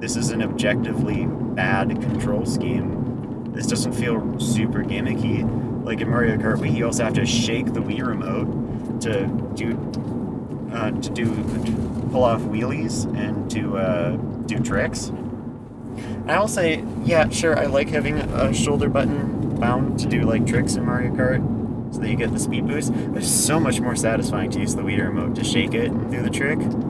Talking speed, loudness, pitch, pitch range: 185 wpm, -22 LUFS, 115 Hz, 115-120 Hz